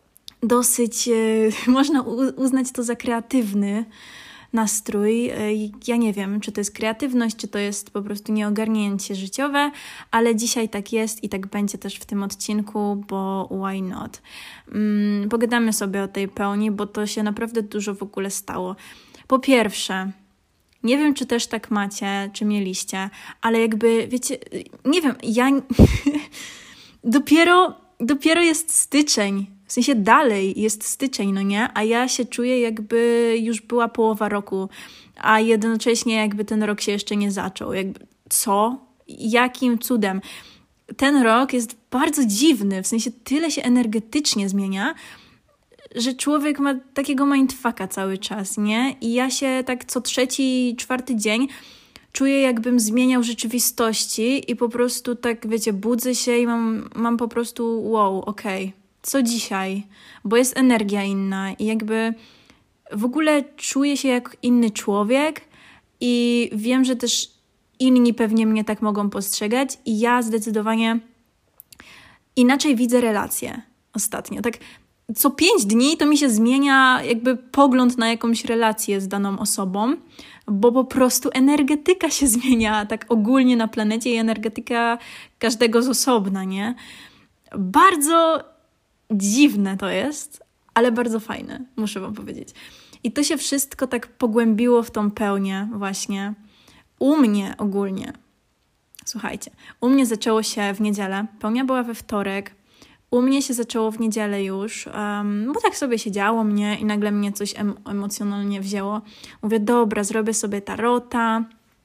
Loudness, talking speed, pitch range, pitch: -21 LUFS, 145 wpm, 210-255 Hz, 230 Hz